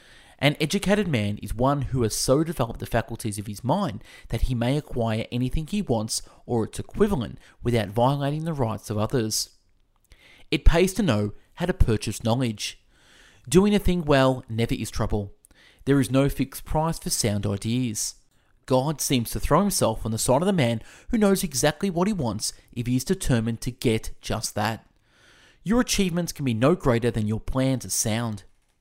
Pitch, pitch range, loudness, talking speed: 120 Hz, 110-145 Hz, -25 LUFS, 185 wpm